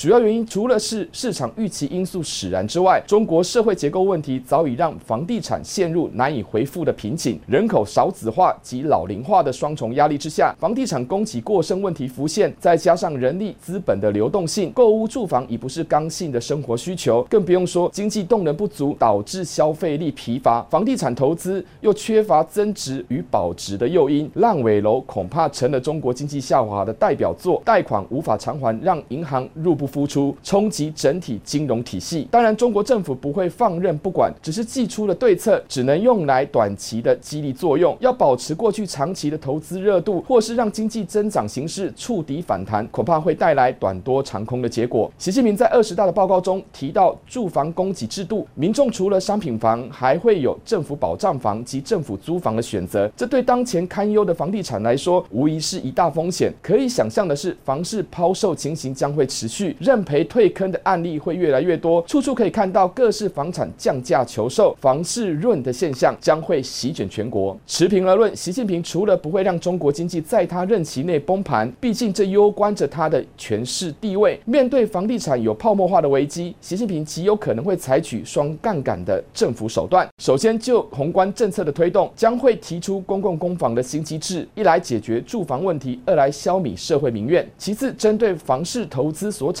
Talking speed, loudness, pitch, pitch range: 305 characters per minute, -20 LUFS, 175 Hz, 135-205 Hz